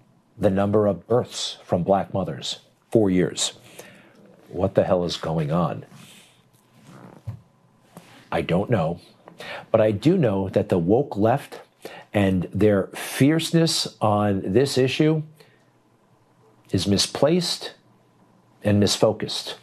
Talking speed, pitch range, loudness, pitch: 110 wpm, 95-140 Hz, -22 LUFS, 105 Hz